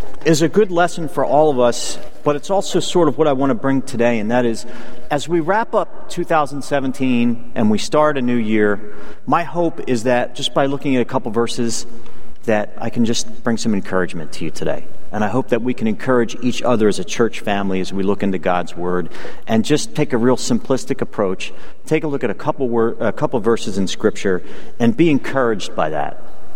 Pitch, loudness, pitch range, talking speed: 120 Hz, -19 LUFS, 110-150 Hz, 215 wpm